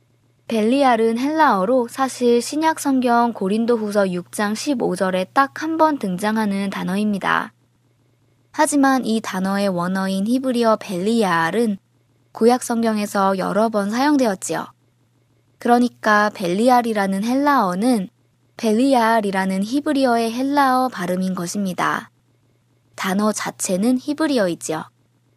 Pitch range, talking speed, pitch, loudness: 180-245 Hz, 270 characters per minute, 210 Hz, -19 LUFS